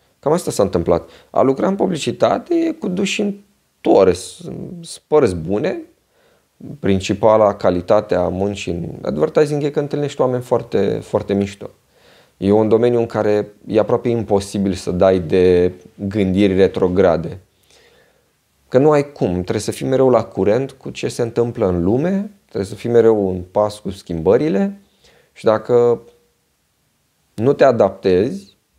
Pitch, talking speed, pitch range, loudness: 110 Hz, 145 wpm, 100-145 Hz, -17 LUFS